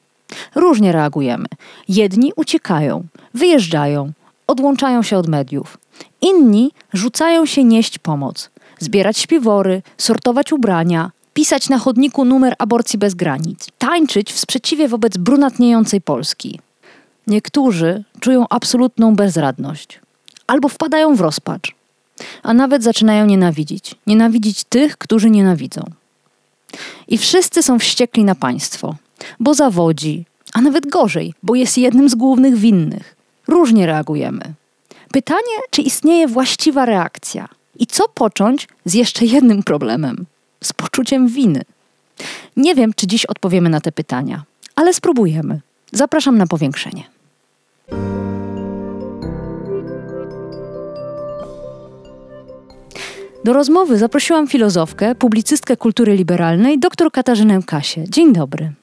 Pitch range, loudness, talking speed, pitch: 165-270 Hz, -14 LUFS, 110 wpm, 225 Hz